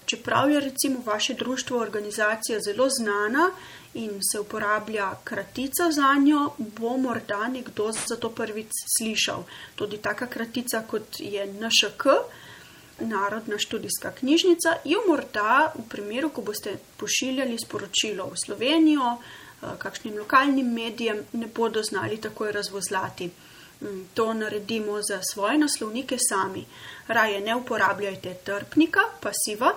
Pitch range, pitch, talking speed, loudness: 210-265 Hz, 225 Hz, 120 wpm, -25 LUFS